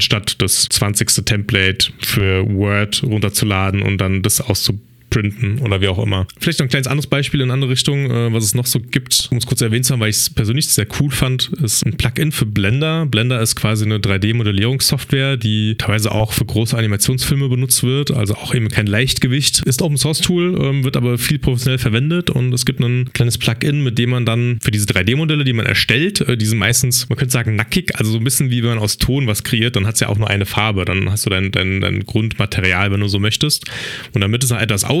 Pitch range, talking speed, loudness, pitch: 105-135 Hz, 230 wpm, -16 LUFS, 120 Hz